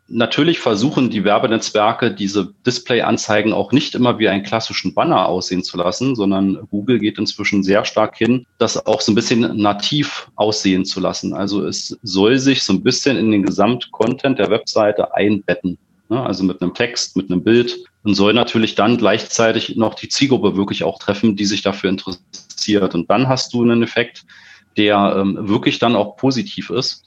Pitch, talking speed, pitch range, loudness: 105 Hz, 175 wpm, 95-120 Hz, -17 LUFS